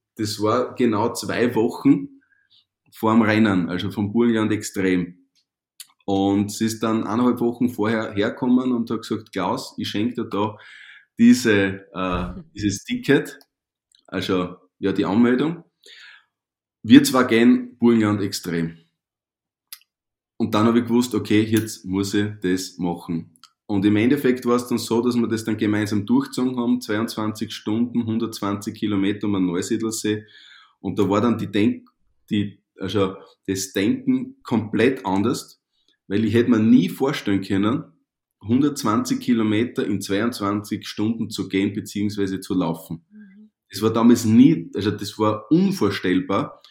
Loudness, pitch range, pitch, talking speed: -21 LUFS, 100-120 Hz, 110 Hz, 140 wpm